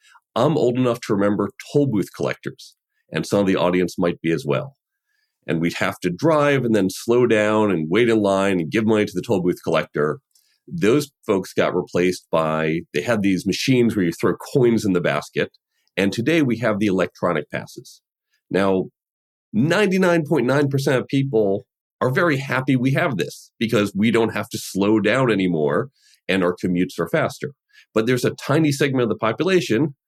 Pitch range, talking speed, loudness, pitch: 95-135 Hz, 185 wpm, -20 LUFS, 110 Hz